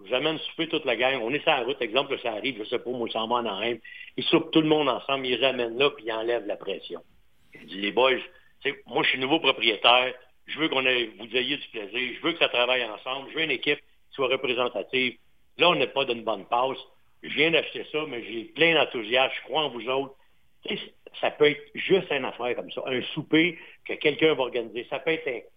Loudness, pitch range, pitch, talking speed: -25 LUFS, 120-155 Hz, 130 Hz, 250 wpm